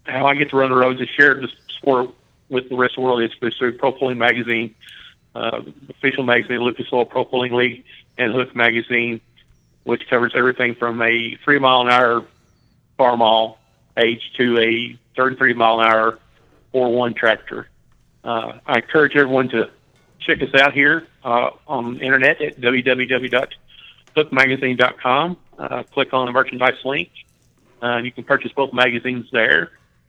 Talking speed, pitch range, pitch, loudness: 165 wpm, 120-130 Hz, 125 Hz, -18 LUFS